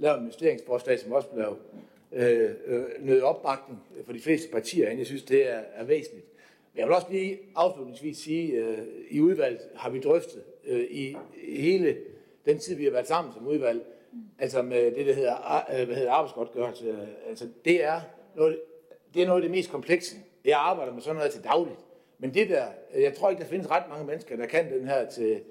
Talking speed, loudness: 210 wpm, -28 LUFS